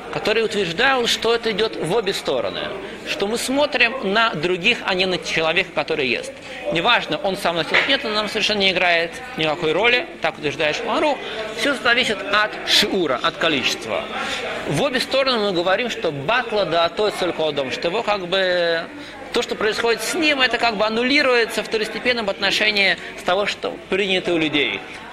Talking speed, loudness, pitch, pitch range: 175 wpm, -19 LUFS, 215 Hz, 180-235 Hz